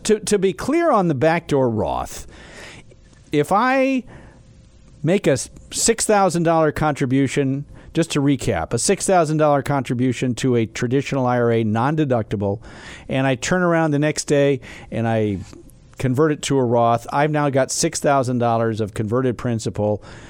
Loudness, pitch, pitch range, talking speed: -19 LUFS, 135 Hz, 115-160 Hz, 140 wpm